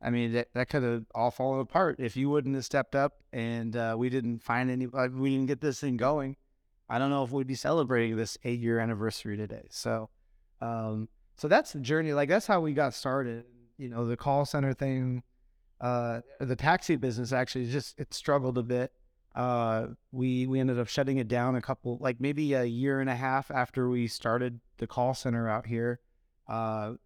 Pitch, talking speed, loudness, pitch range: 125 Hz, 205 wpm, -31 LUFS, 115-135 Hz